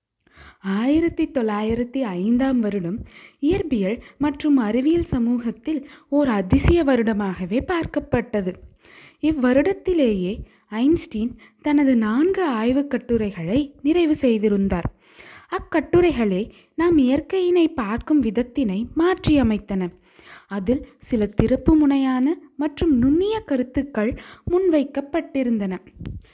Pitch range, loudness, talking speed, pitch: 225-310 Hz, -21 LUFS, 75 wpm, 265 Hz